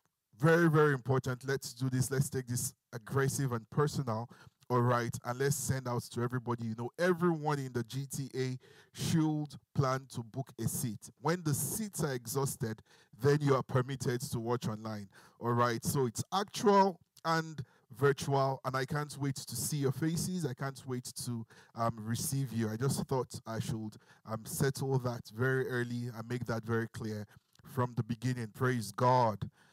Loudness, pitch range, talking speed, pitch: -34 LUFS, 120-145 Hz, 175 wpm, 130 Hz